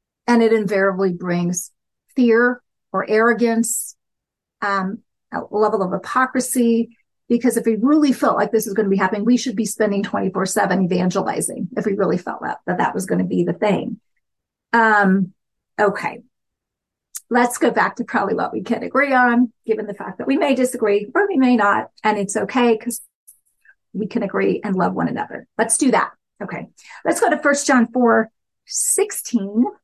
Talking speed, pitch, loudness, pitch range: 175 wpm, 225 Hz, -19 LUFS, 200-250 Hz